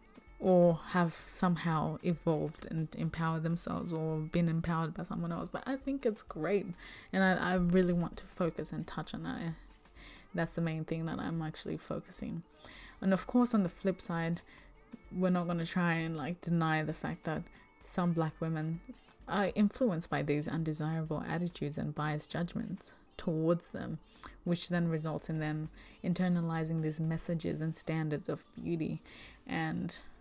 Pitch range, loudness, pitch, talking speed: 160-185 Hz, -35 LUFS, 170 Hz, 165 wpm